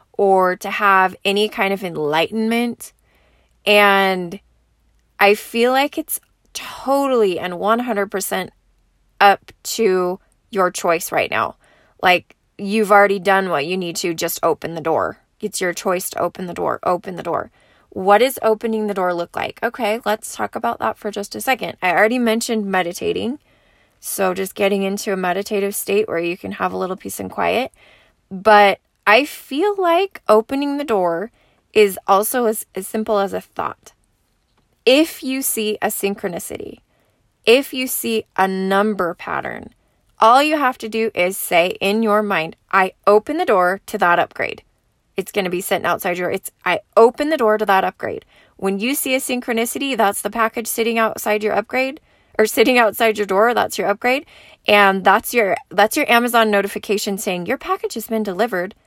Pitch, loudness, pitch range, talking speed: 205 Hz, -18 LUFS, 190-230 Hz, 175 wpm